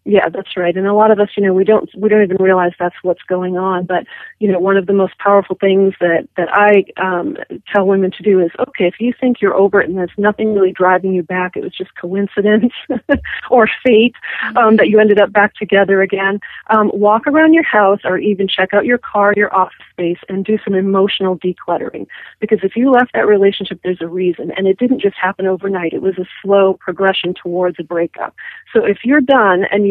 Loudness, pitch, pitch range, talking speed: -14 LUFS, 195 Hz, 185-210 Hz, 230 wpm